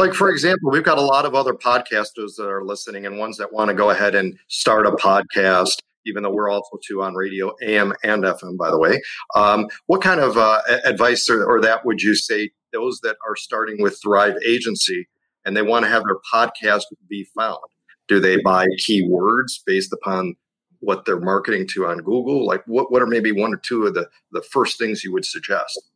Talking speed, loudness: 215 wpm, -19 LUFS